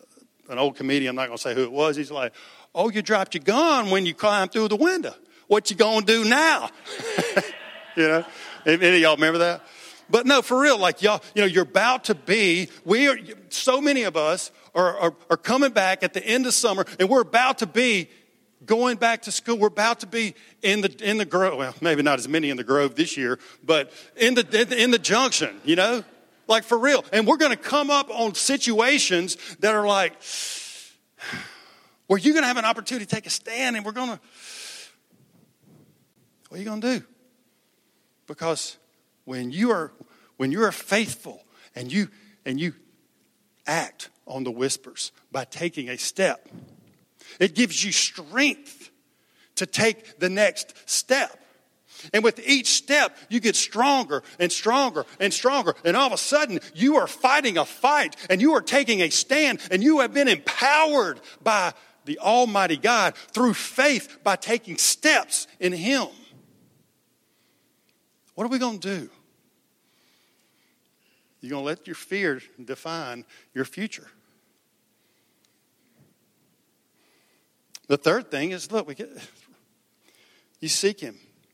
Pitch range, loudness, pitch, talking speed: 170-250 Hz, -22 LUFS, 215 Hz, 175 wpm